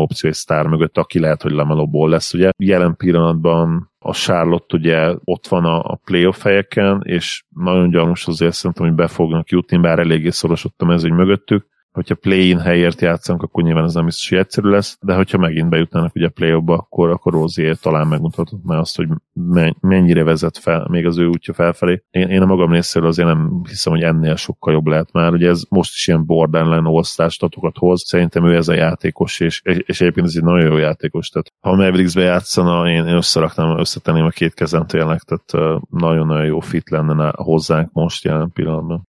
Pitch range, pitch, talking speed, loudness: 80-90 Hz, 85 Hz, 190 wpm, -15 LUFS